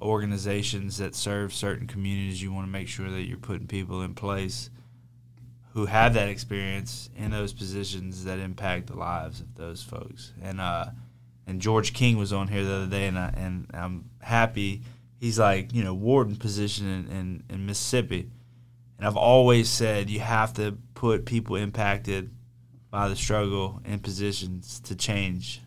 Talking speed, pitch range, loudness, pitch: 170 wpm, 95-120 Hz, -27 LUFS, 105 Hz